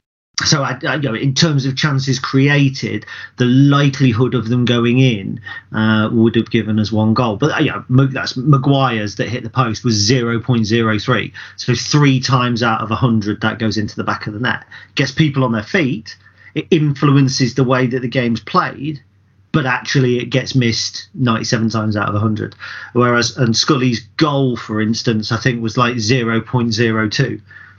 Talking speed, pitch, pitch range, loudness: 180 wpm, 125 Hz, 110-135 Hz, -16 LUFS